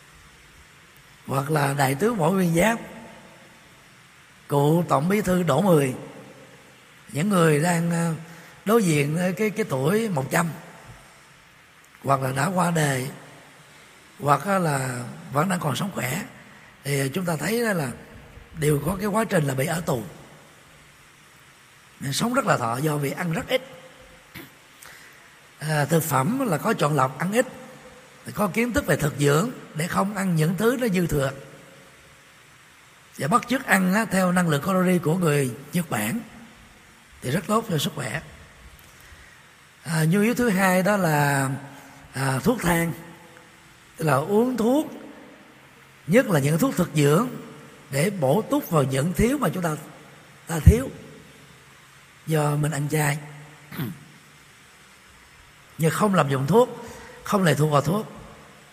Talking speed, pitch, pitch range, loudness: 150 wpm, 170 Hz, 145-205 Hz, -23 LUFS